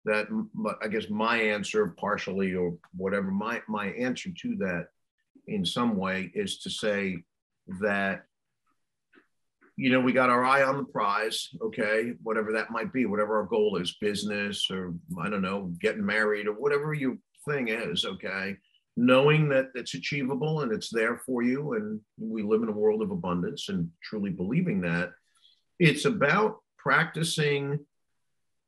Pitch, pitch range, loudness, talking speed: 120 Hz, 105-170 Hz, -28 LUFS, 160 wpm